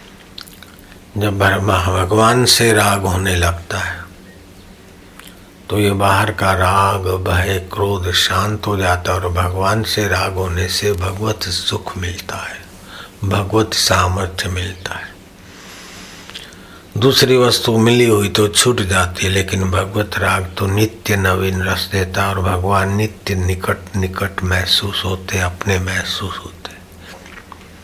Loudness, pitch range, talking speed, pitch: -16 LUFS, 95-100 Hz, 125 wpm, 95 Hz